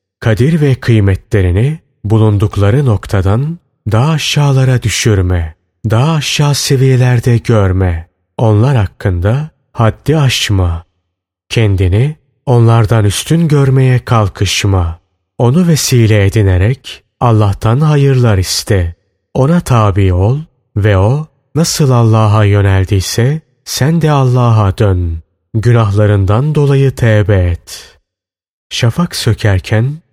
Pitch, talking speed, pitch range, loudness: 110 Hz, 90 wpm, 100-135 Hz, -11 LUFS